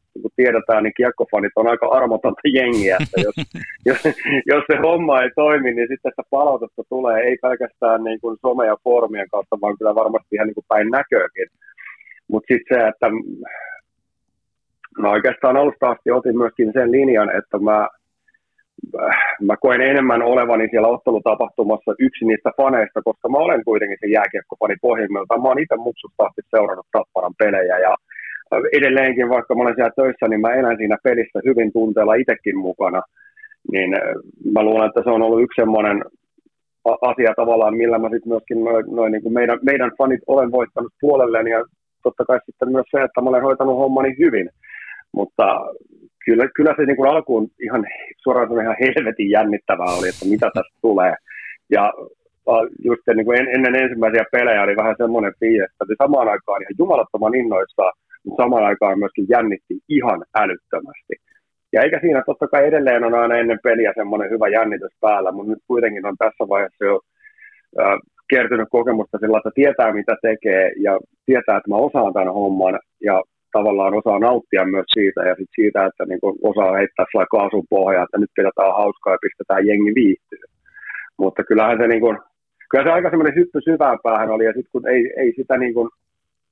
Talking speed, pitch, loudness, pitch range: 170 wpm, 120 Hz, -17 LUFS, 110-140 Hz